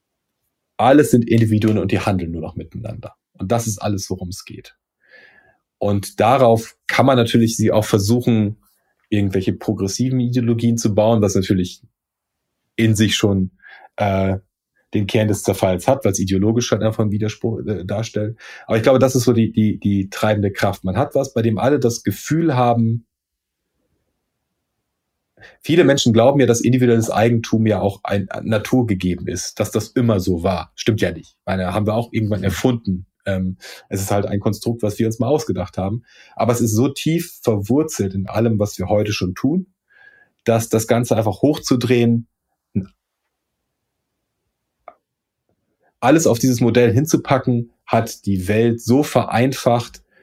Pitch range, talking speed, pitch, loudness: 100-120 Hz, 160 wpm, 110 Hz, -18 LUFS